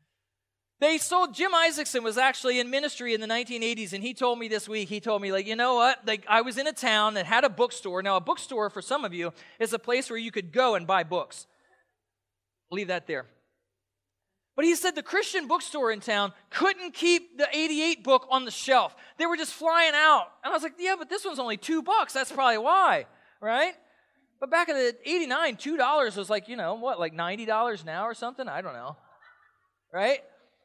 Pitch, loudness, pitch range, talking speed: 250 Hz, -26 LUFS, 215-315 Hz, 220 wpm